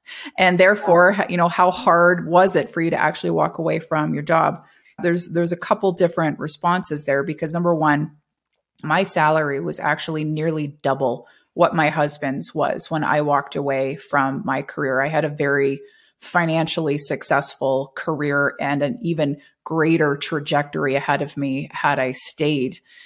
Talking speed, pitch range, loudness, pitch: 160 wpm, 145-175 Hz, -20 LUFS, 155 Hz